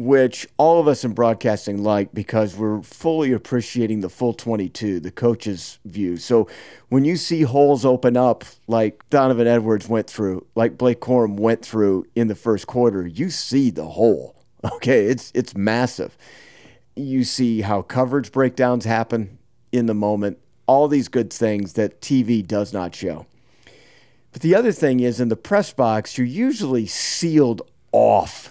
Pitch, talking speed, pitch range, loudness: 120 Hz, 160 wpm, 105-130 Hz, -20 LUFS